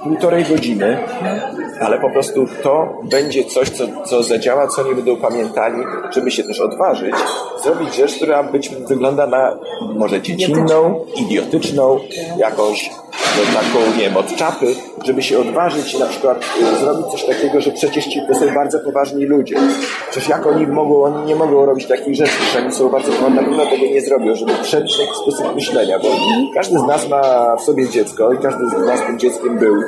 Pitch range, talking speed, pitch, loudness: 135-175 Hz, 185 wpm, 150 Hz, -15 LUFS